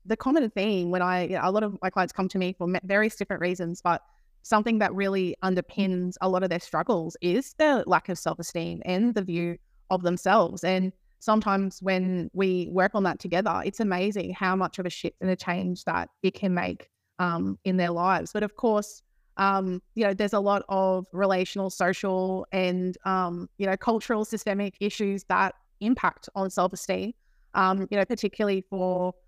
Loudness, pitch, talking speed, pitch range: -27 LUFS, 190 Hz, 195 wpm, 180-200 Hz